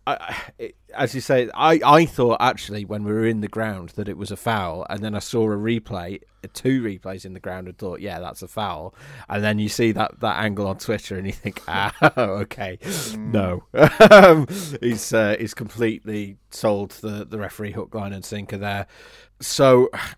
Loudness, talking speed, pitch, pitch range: -20 LUFS, 195 wpm, 105 Hz, 100-115 Hz